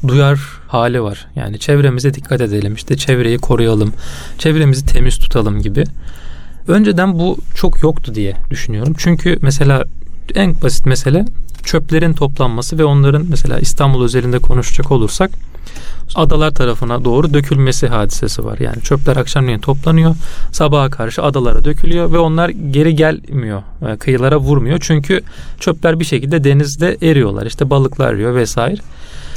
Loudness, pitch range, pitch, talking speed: -14 LUFS, 115-155 Hz, 135 Hz, 130 wpm